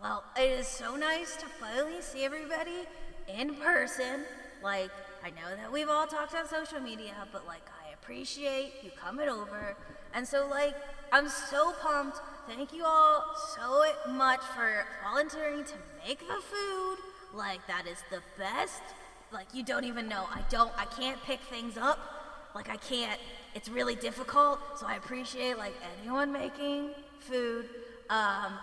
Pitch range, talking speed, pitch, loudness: 230-295 Hz, 160 wpm, 275 Hz, -33 LUFS